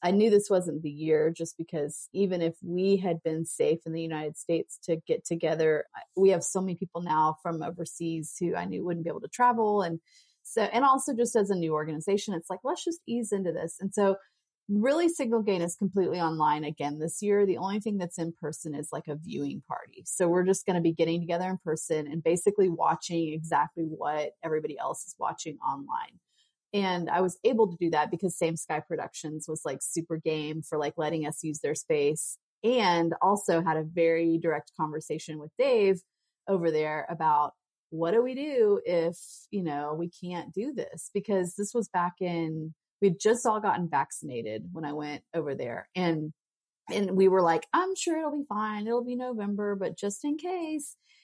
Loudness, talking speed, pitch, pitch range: -29 LUFS, 200 wpm, 175 Hz, 160-205 Hz